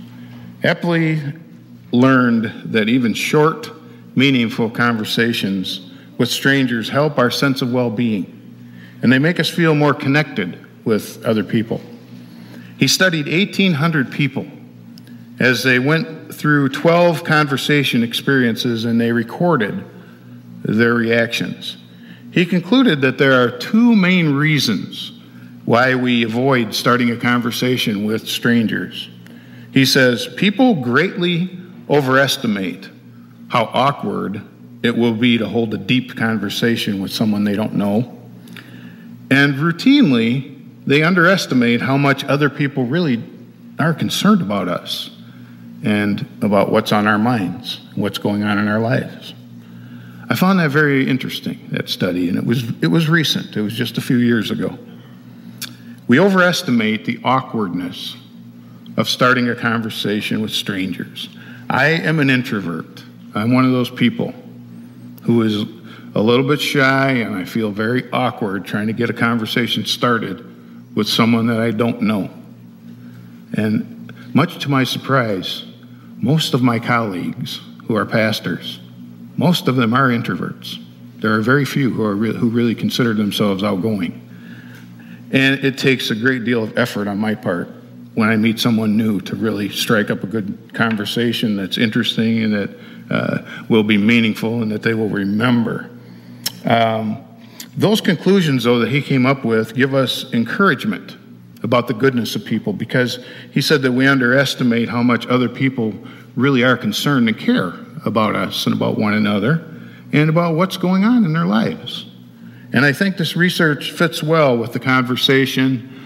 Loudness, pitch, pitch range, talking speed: -17 LUFS, 120 Hz, 85-140 Hz, 145 wpm